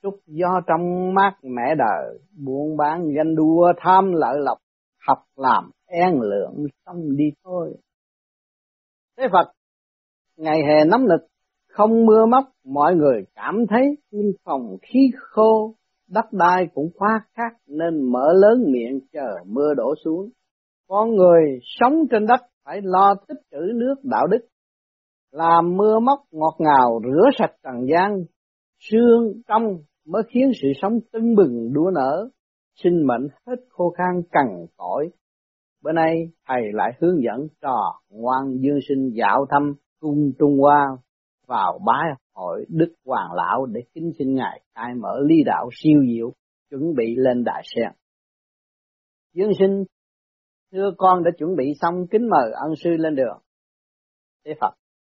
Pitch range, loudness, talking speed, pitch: 145-210 Hz, -20 LUFS, 150 wpm, 170 Hz